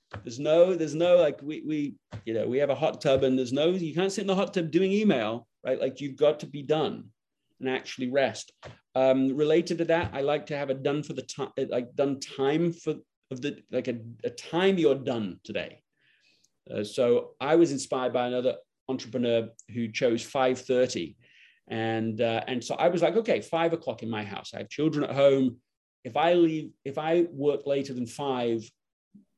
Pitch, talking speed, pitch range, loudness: 140 Hz, 205 wpm, 125-165 Hz, -27 LUFS